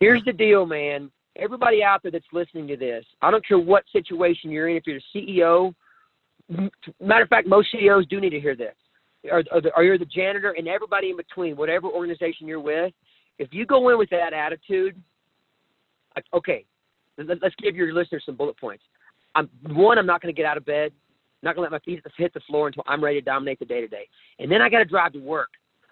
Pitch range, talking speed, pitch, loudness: 155-200 Hz, 220 wpm, 175 Hz, -22 LUFS